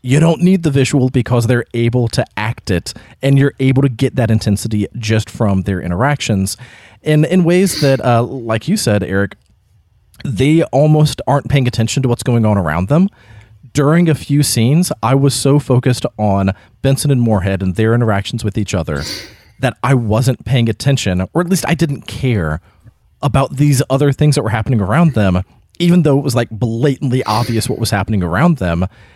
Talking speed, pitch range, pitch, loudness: 190 wpm, 105-140 Hz, 120 Hz, -14 LUFS